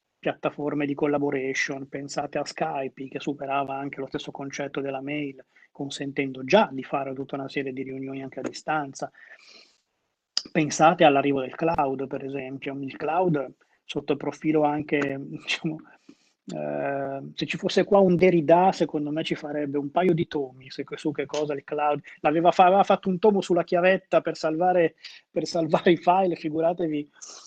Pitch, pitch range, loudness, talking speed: 150 Hz, 140-165 Hz, -25 LUFS, 160 wpm